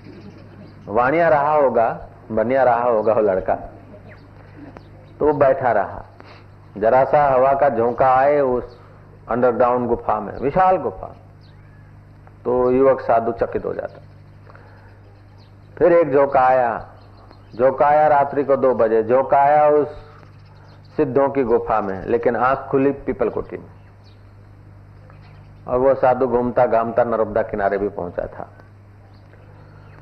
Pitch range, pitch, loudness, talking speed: 100-130 Hz, 110 Hz, -18 LUFS, 120 wpm